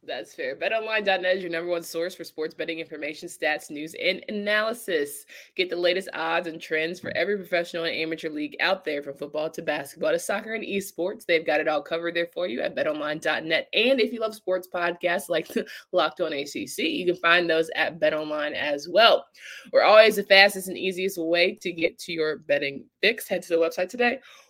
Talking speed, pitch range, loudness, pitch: 205 wpm, 160-195 Hz, -25 LUFS, 175 Hz